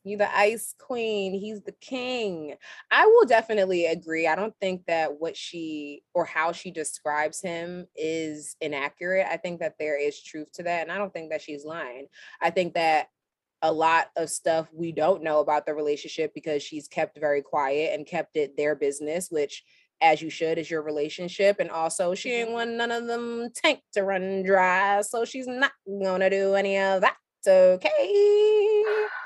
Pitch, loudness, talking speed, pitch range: 180 Hz, -25 LUFS, 185 wpm, 155-215 Hz